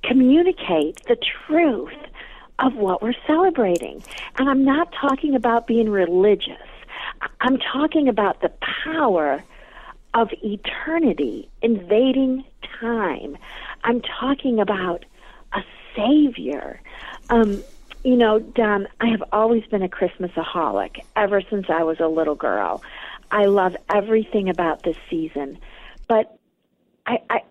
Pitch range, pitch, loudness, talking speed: 200-265 Hz, 230 Hz, -21 LUFS, 120 wpm